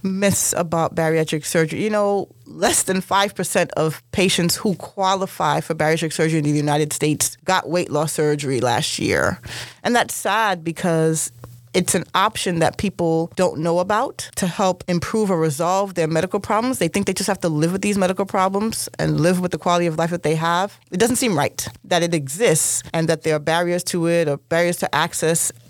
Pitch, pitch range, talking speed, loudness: 170 Hz, 160-190 Hz, 200 wpm, -20 LUFS